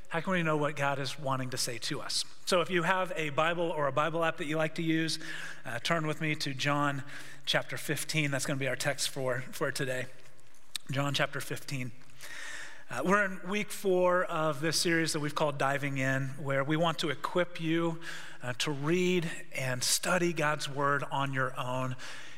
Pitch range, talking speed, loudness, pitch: 135-165 Hz, 205 wpm, -31 LUFS, 150 Hz